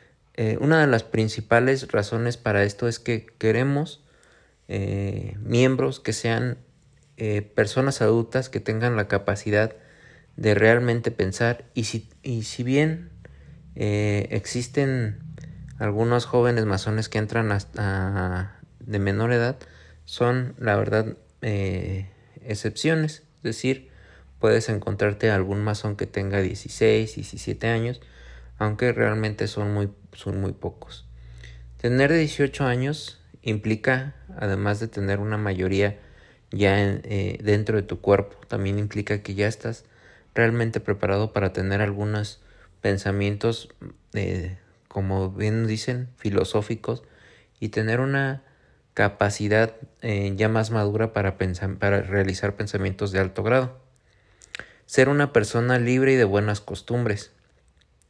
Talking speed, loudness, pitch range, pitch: 125 wpm, -24 LUFS, 100-120 Hz, 110 Hz